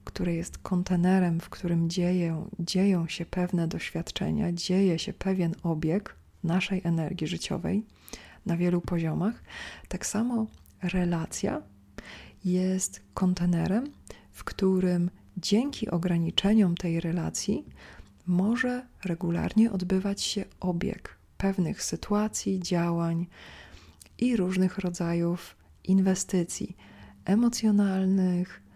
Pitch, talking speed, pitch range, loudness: 180 Hz, 90 wpm, 170-195 Hz, -28 LUFS